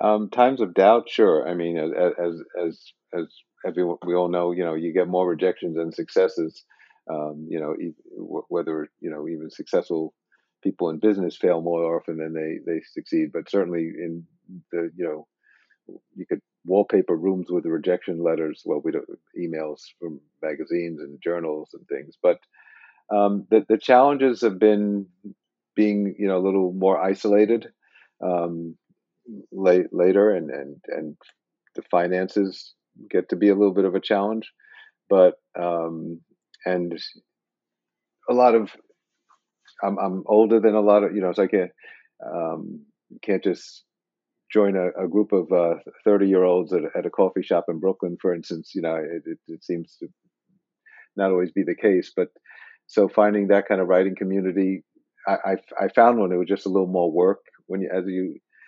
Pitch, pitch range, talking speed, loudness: 95 Hz, 85-105 Hz, 175 wpm, -23 LUFS